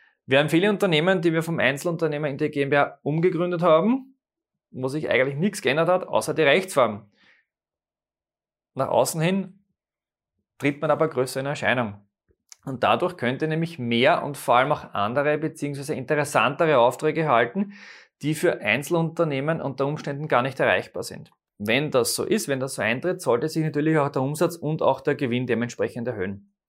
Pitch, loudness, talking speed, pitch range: 150 Hz, -23 LUFS, 165 wpm, 135-170 Hz